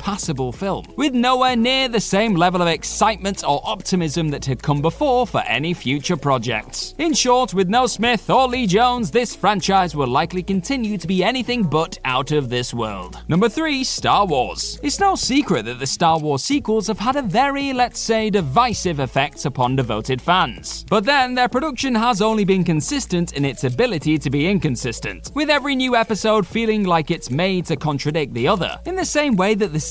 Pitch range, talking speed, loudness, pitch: 155-245 Hz, 195 wpm, -19 LUFS, 195 Hz